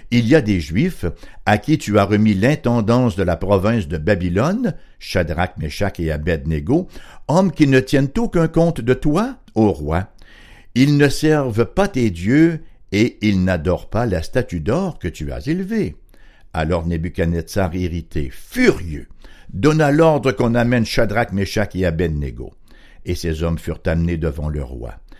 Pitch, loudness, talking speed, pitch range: 105 Hz, -18 LUFS, 160 wpm, 85-135 Hz